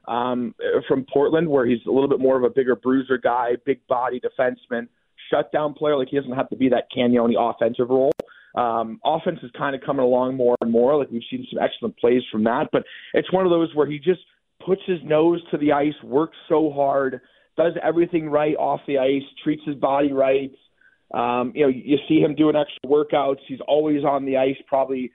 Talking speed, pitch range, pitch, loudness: 210 wpm, 125-150 Hz, 135 Hz, -21 LUFS